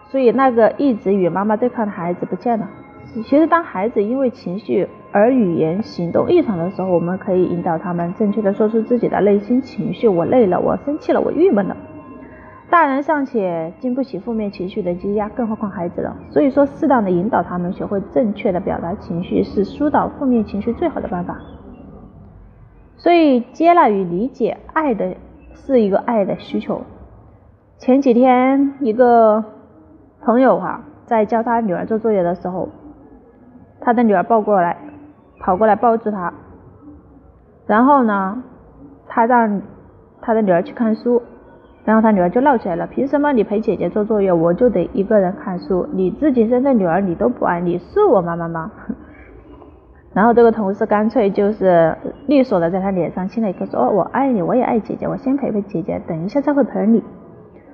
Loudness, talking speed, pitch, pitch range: -17 LUFS, 280 characters per minute, 220 Hz, 185-250 Hz